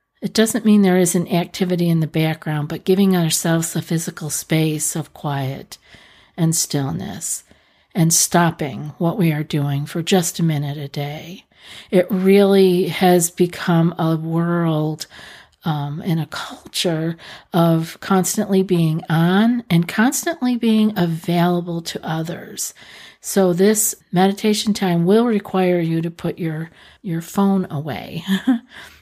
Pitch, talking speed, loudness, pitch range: 175 Hz, 130 wpm, -19 LUFS, 160-195 Hz